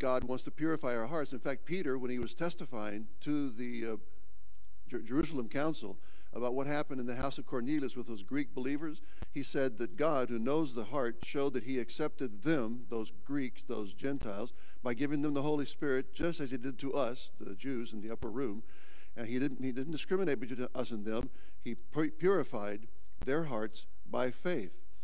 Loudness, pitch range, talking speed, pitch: -37 LUFS, 115-145 Hz, 195 wpm, 130 Hz